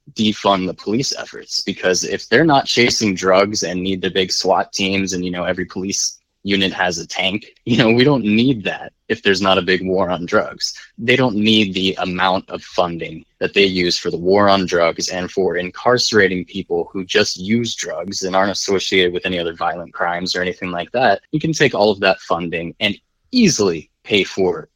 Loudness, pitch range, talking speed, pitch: -17 LUFS, 90-110 Hz, 210 wpm, 95 Hz